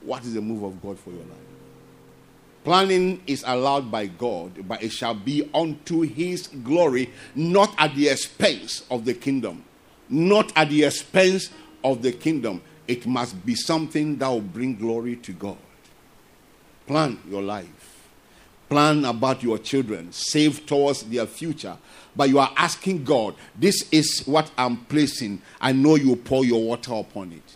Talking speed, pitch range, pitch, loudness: 160 wpm, 115-155 Hz, 135 Hz, -22 LUFS